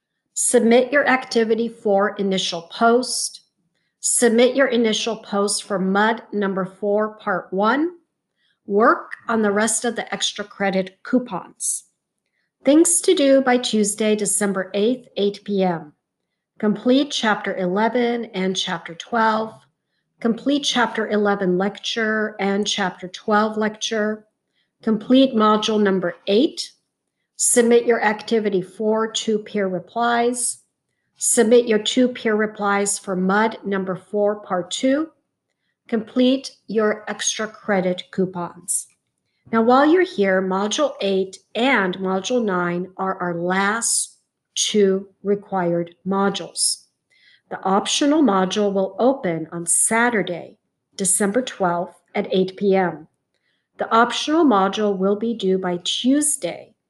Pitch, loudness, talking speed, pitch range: 210 Hz, -20 LUFS, 115 wpm, 190-235 Hz